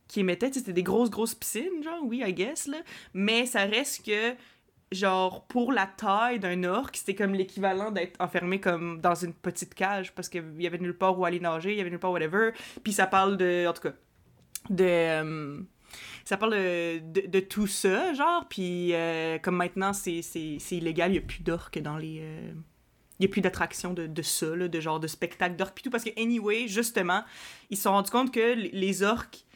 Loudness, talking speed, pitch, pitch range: -29 LUFS, 220 wpm, 190 Hz, 175-215 Hz